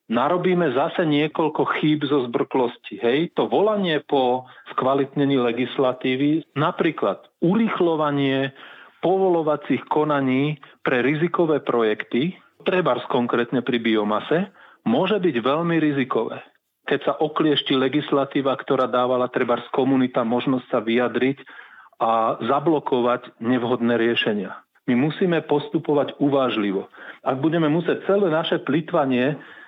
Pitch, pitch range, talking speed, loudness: 140 Hz, 125-155 Hz, 105 wpm, -22 LUFS